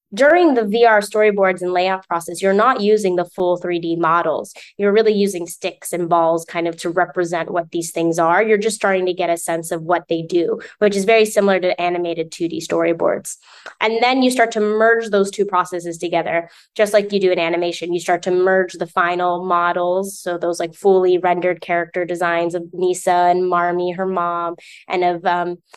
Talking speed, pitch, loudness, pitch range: 200 wpm, 180 Hz, -18 LUFS, 175-200 Hz